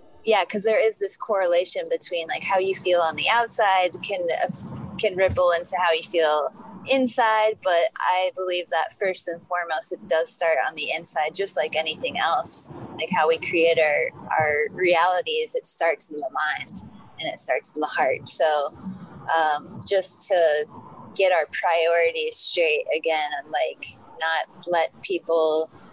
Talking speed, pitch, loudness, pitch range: 165 wpm, 180 Hz, -23 LUFS, 165-220 Hz